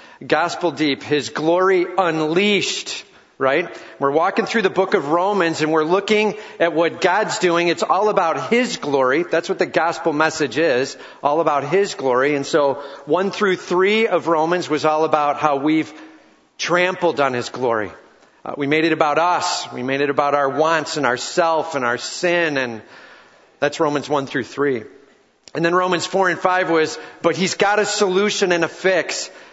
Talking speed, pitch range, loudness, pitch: 185 wpm, 155-190 Hz, -19 LUFS, 170 Hz